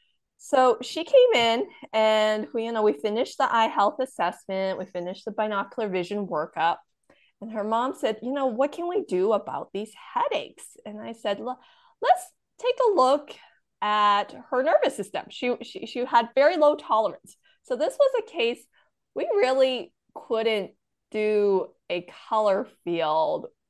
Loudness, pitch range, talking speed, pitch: -25 LUFS, 210-315 Hz, 160 wpm, 235 Hz